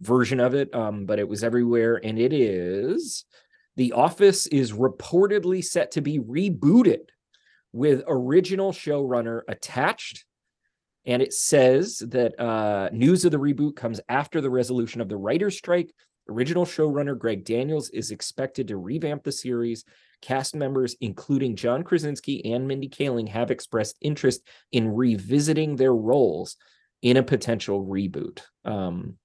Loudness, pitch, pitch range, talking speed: -24 LUFS, 130 Hz, 115-150 Hz, 145 wpm